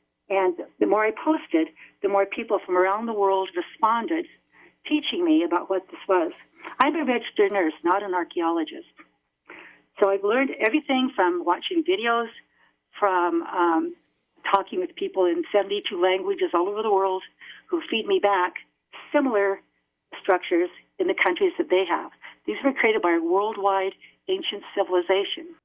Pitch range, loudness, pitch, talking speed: 185-300 Hz, -24 LUFS, 200 Hz, 150 wpm